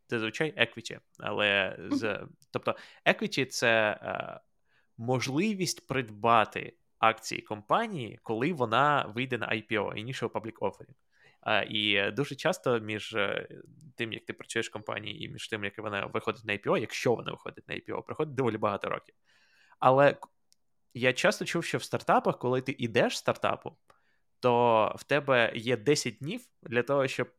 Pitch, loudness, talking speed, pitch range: 125 Hz, -30 LUFS, 165 wpm, 110-140 Hz